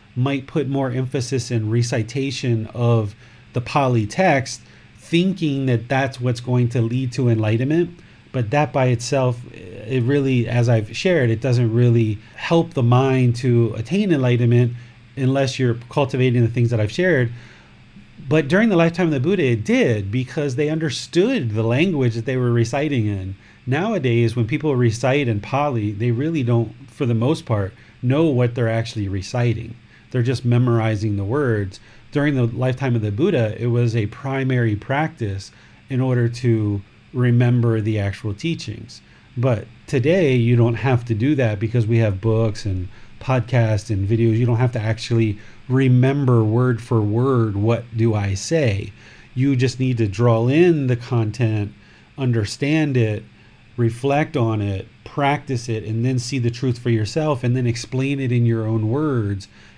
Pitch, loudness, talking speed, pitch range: 120 Hz, -20 LUFS, 165 wpm, 115-135 Hz